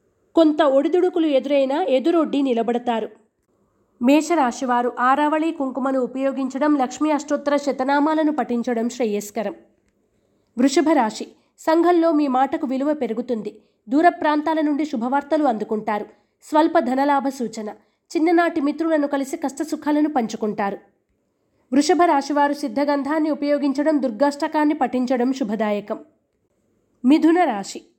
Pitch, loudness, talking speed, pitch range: 280 Hz, -20 LUFS, 90 wpm, 250-310 Hz